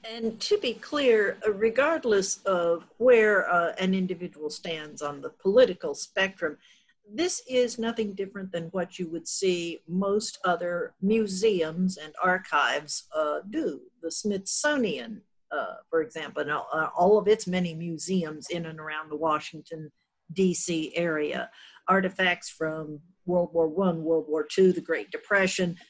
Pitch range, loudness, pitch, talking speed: 165-215 Hz, -27 LUFS, 185 Hz, 145 wpm